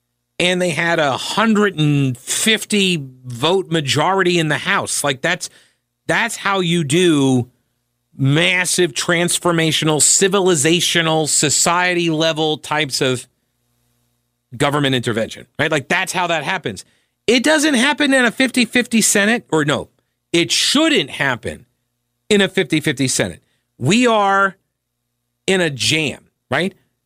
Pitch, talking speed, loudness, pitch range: 160 Hz, 120 wpm, -16 LUFS, 130-190 Hz